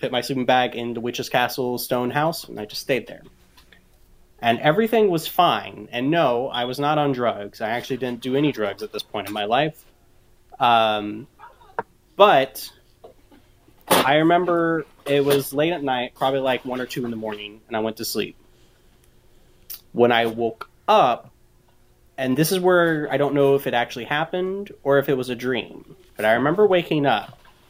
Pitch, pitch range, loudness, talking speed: 130 Hz, 120-150 Hz, -21 LUFS, 185 wpm